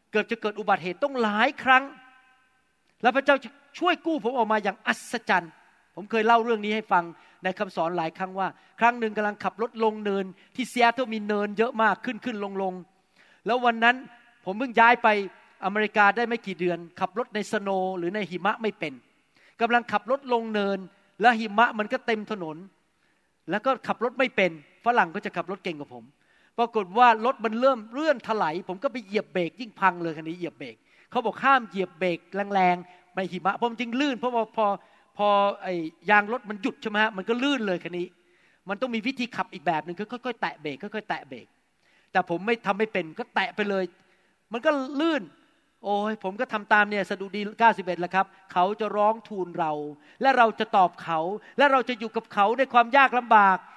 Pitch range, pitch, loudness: 190-240 Hz, 210 Hz, -25 LUFS